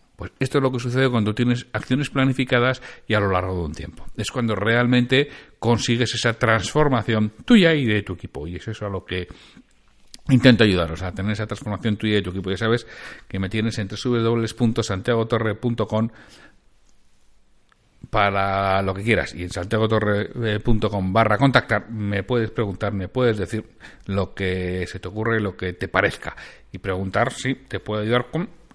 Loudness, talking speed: -22 LUFS, 175 wpm